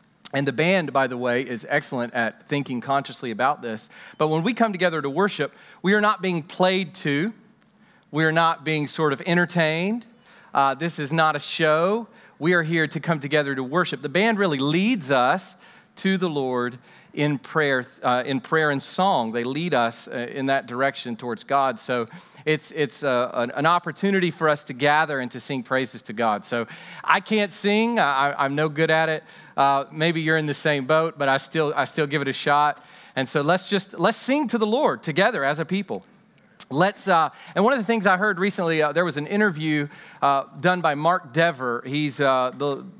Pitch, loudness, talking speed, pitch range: 155 Hz, -23 LUFS, 205 wpm, 140-180 Hz